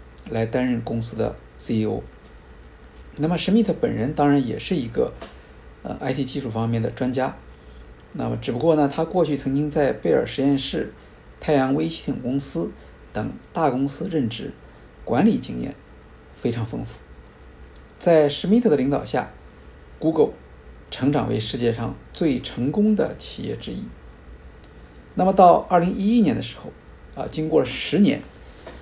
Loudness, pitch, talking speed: -22 LUFS, 115 Hz, 240 characters per minute